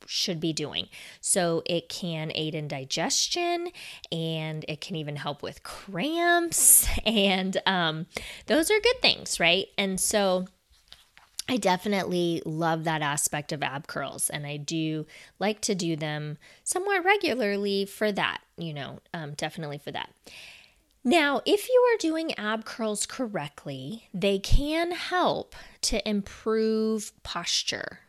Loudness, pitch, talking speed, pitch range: -26 LUFS, 185 Hz, 135 wpm, 160-225 Hz